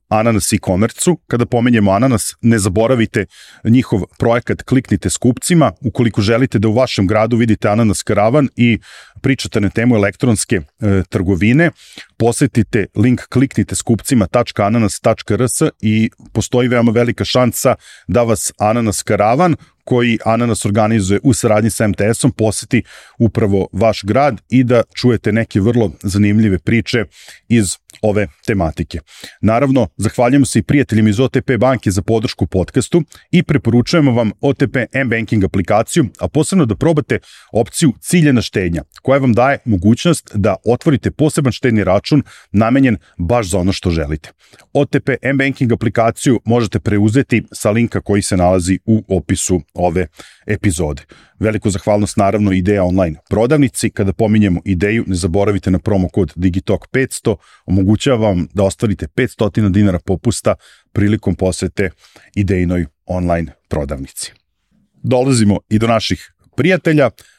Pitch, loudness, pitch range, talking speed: 110 Hz, -15 LUFS, 100-125 Hz, 130 wpm